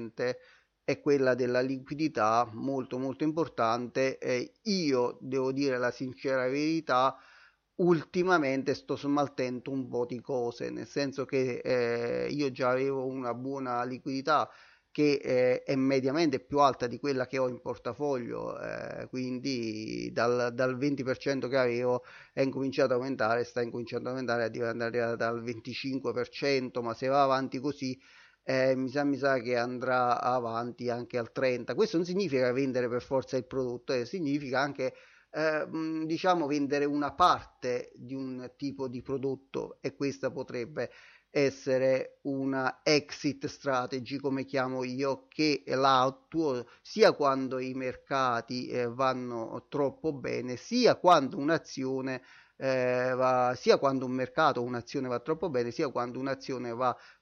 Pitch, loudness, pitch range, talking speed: 130 Hz, -30 LUFS, 125-140 Hz, 145 wpm